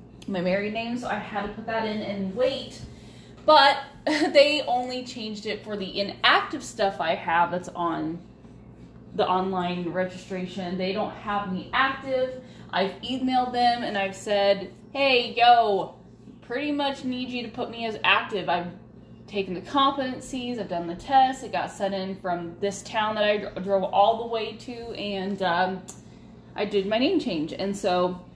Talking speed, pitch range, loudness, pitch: 170 wpm, 190-250 Hz, -25 LUFS, 210 Hz